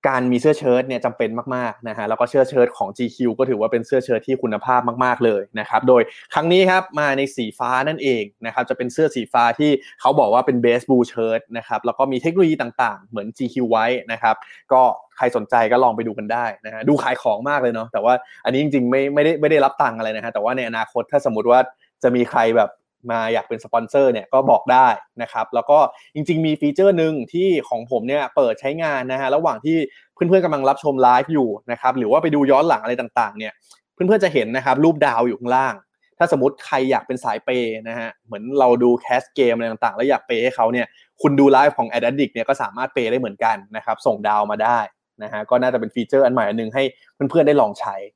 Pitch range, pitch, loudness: 115-145 Hz, 125 Hz, -19 LUFS